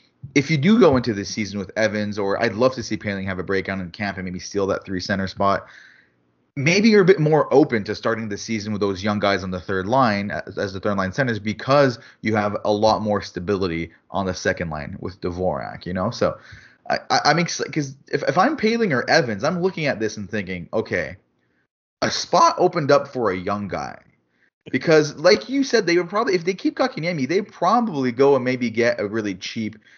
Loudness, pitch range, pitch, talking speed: -21 LUFS, 100-150 Hz, 110 Hz, 225 wpm